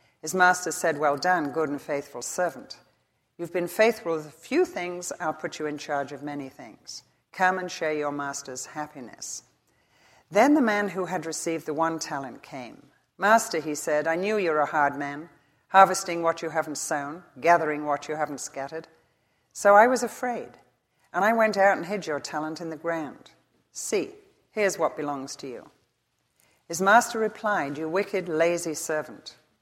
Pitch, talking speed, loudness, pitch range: 160 Hz, 175 wpm, -26 LUFS, 150-185 Hz